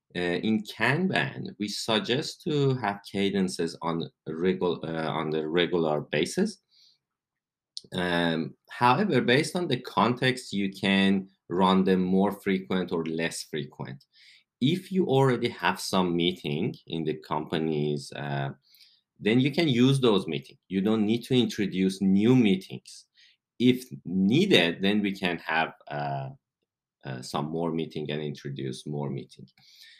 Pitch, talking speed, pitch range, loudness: 95 Hz, 135 wpm, 80-120 Hz, -27 LUFS